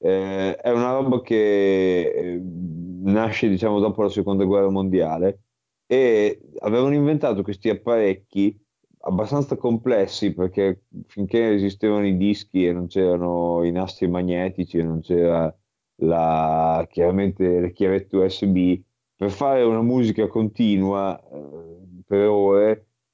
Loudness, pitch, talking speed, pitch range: -21 LUFS, 100 Hz, 120 wpm, 90-110 Hz